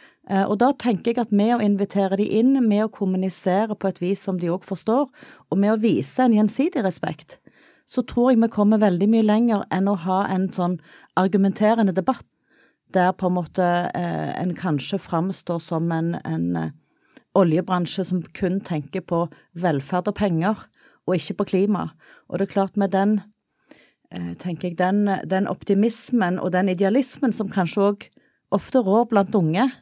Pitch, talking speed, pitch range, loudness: 195 Hz, 170 wpm, 180-215 Hz, -22 LUFS